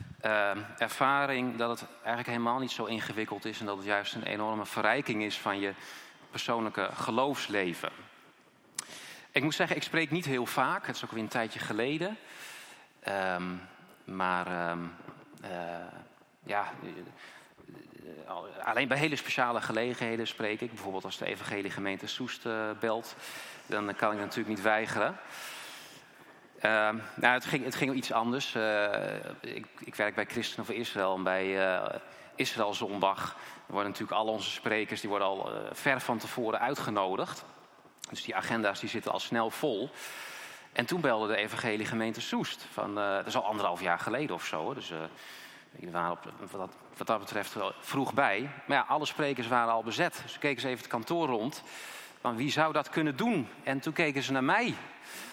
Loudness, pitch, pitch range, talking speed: -32 LUFS, 115 Hz, 105-130 Hz, 175 wpm